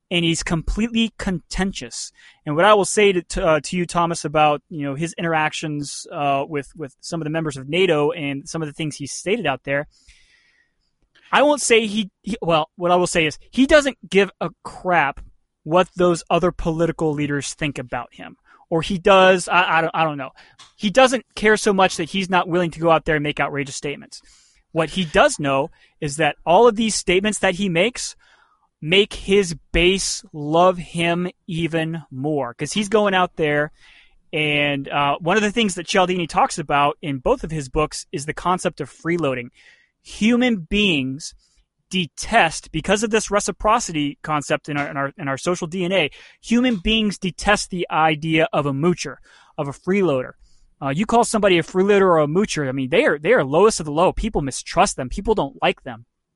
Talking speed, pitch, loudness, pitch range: 200 wpm, 170 Hz, -20 LUFS, 150-195 Hz